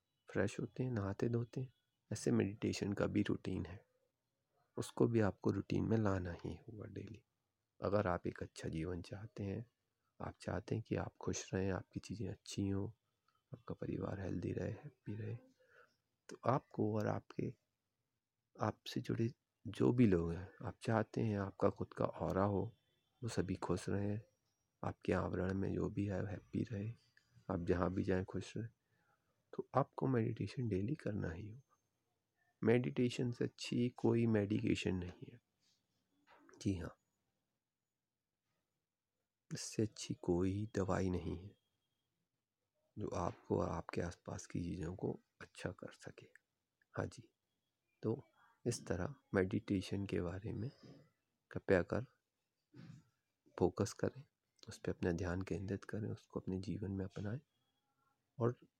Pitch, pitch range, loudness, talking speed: 105 Hz, 95-115 Hz, -41 LUFS, 140 wpm